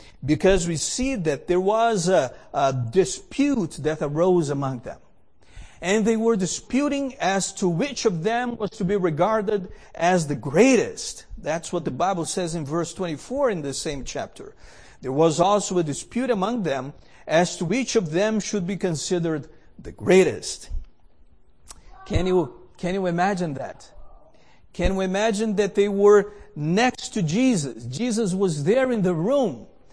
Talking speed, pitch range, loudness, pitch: 160 wpm, 165-220 Hz, -23 LUFS, 185 Hz